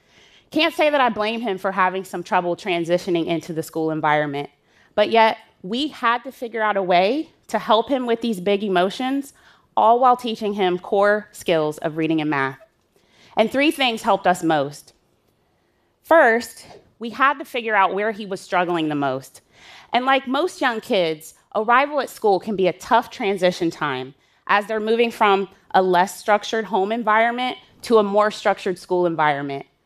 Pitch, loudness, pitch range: 205 Hz, -20 LUFS, 175-235 Hz